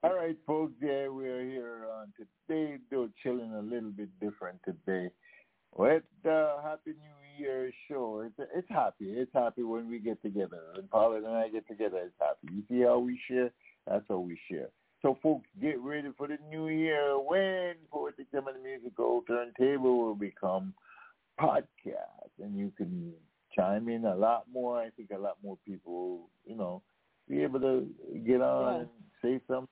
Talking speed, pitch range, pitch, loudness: 185 wpm, 110-145 Hz, 125 Hz, -33 LUFS